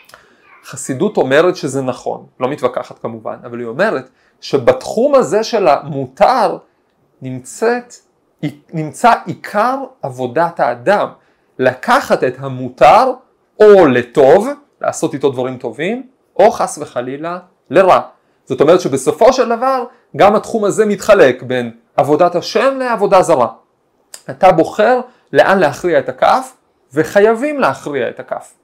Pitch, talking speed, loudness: 180 Hz, 115 wpm, -13 LUFS